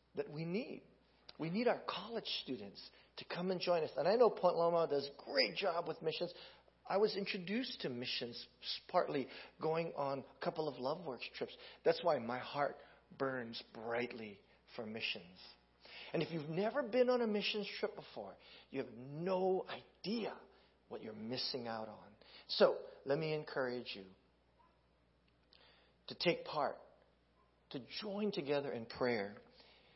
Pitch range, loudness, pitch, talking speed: 120-185 Hz, -39 LUFS, 150 Hz, 155 wpm